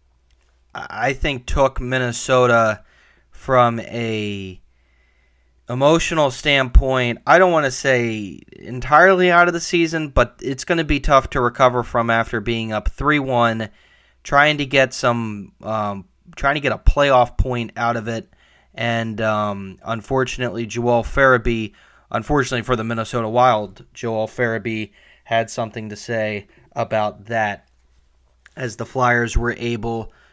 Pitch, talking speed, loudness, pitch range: 120 Hz, 135 wpm, -19 LUFS, 110-130 Hz